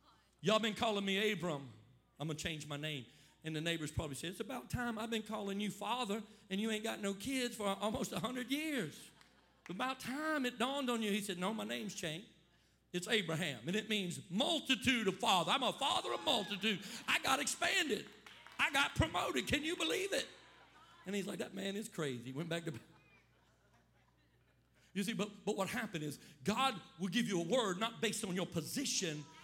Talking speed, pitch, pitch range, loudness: 200 wpm, 205 Hz, 170-230 Hz, -38 LUFS